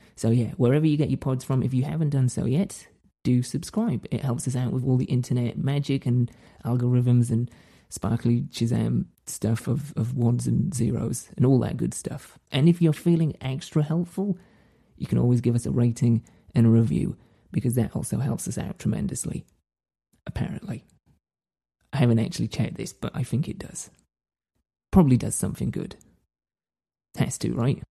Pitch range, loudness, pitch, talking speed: 115-135 Hz, -25 LUFS, 125 Hz, 175 wpm